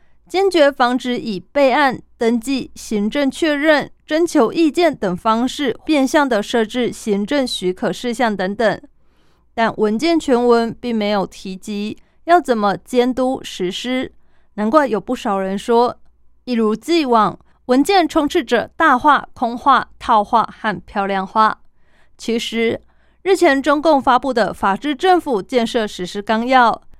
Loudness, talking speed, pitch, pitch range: -17 LUFS, 210 characters per minute, 240 Hz, 215-285 Hz